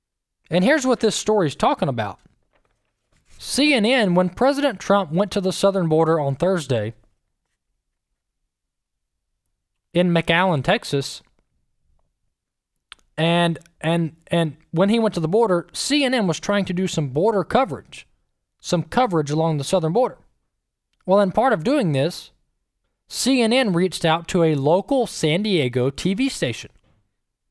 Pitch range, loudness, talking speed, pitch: 155-210 Hz, -20 LUFS, 130 wpm, 175 Hz